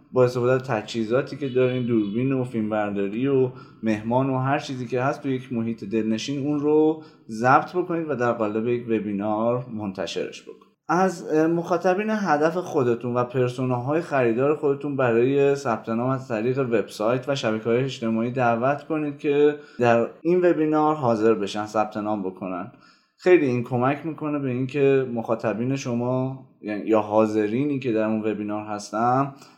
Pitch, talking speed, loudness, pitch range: 125 Hz, 155 wpm, -23 LUFS, 115-145 Hz